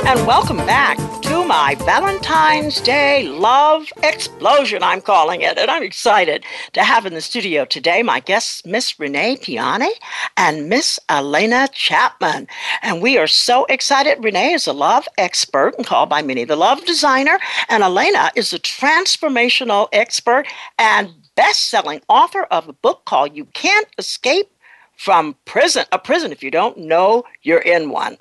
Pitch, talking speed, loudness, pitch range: 305 Hz, 160 wpm, -15 LUFS, 245-395 Hz